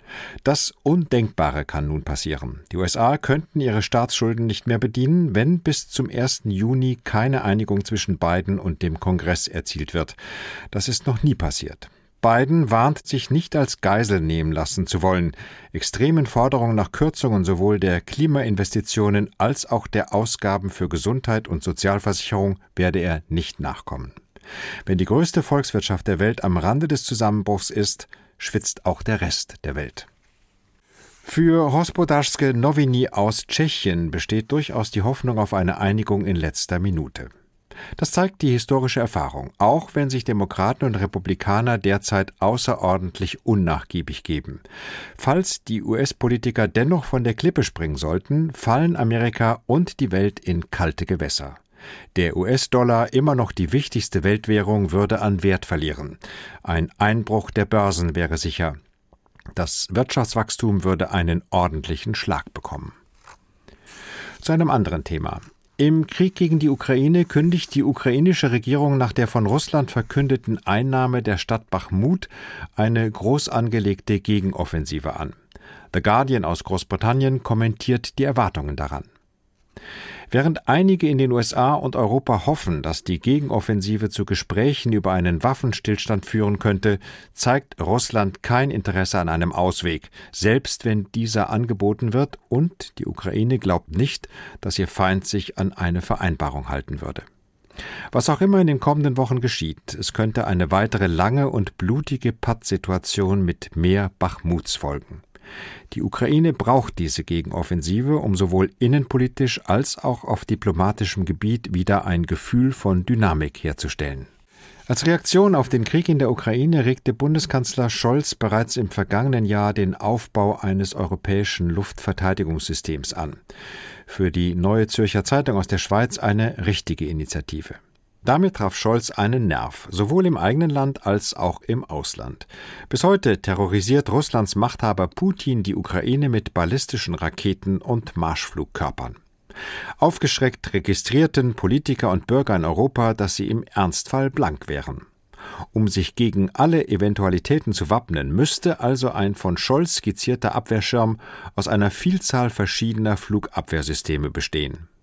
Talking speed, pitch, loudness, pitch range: 140 wpm, 105 Hz, -21 LUFS, 95-130 Hz